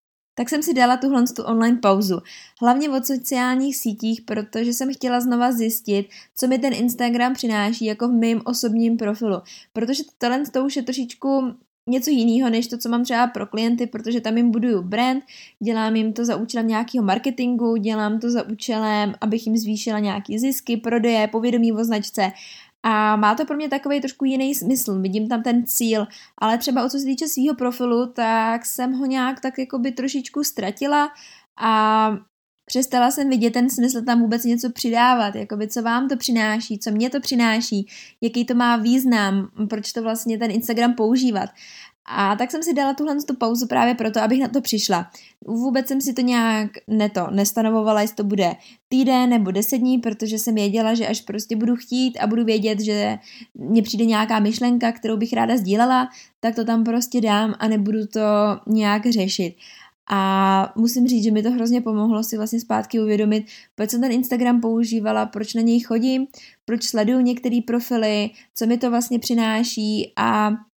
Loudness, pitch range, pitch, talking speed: -21 LUFS, 220-250 Hz, 235 Hz, 185 wpm